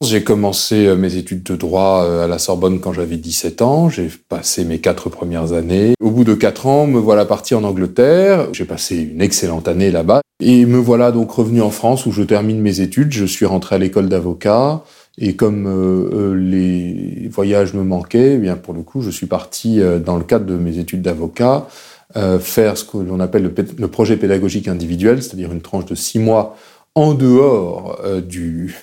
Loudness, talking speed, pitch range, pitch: -15 LUFS, 190 wpm, 90-115 Hz, 100 Hz